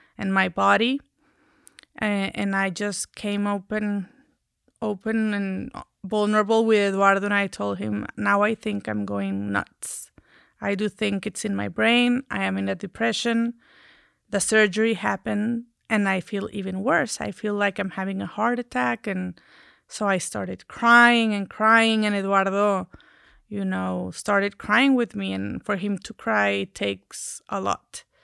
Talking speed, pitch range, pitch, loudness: 155 wpm, 190-225 Hz, 205 Hz, -23 LUFS